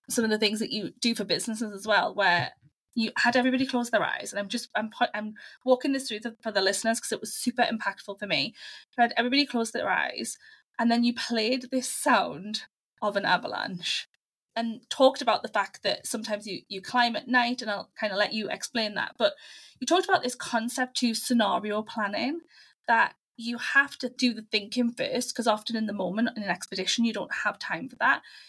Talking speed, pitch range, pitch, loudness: 220 wpm, 215-250 Hz, 230 Hz, -27 LUFS